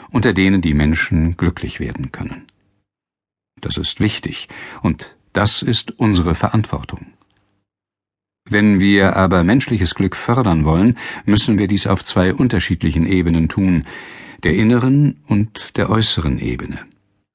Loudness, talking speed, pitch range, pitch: -16 LUFS, 125 wpm, 85-105 Hz, 100 Hz